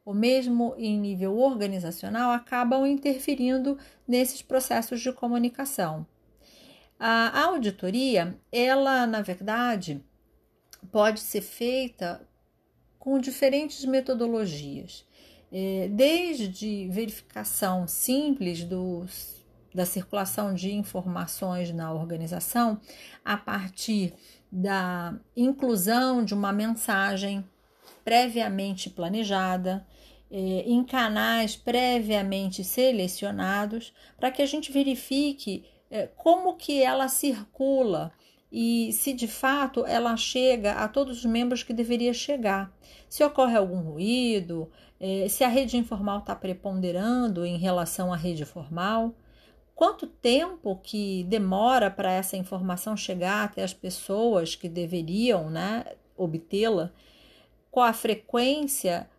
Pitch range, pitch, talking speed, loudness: 190-255 Hz, 220 Hz, 105 wpm, -27 LUFS